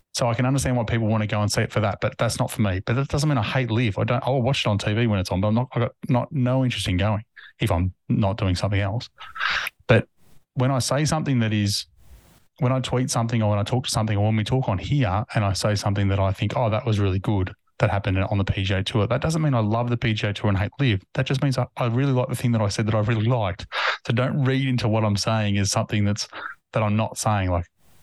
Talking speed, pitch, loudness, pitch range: 290 wpm, 110 Hz, -23 LUFS, 105-125 Hz